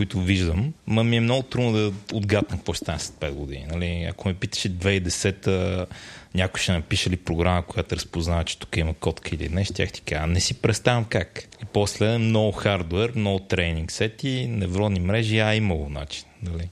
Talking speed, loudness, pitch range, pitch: 190 wpm, -24 LUFS, 85-110 Hz, 95 Hz